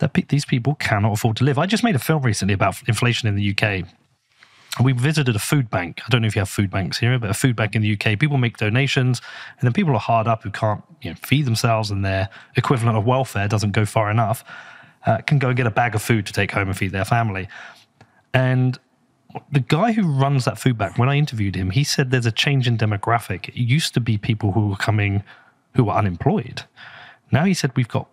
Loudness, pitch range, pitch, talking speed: -20 LUFS, 105-135 Hz, 120 Hz, 245 wpm